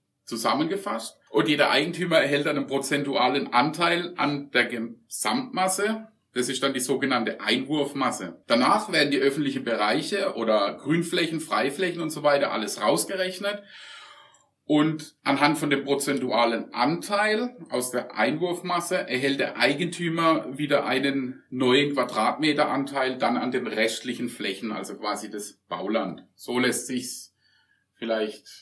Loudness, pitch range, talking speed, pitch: -25 LUFS, 125-170 Hz, 125 wpm, 145 Hz